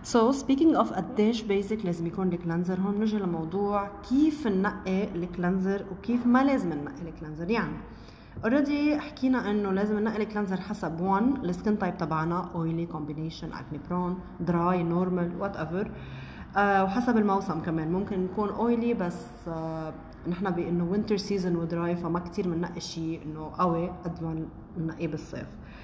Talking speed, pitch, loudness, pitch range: 145 wpm, 185 Hz, -28 LUFS, 170-210 Hz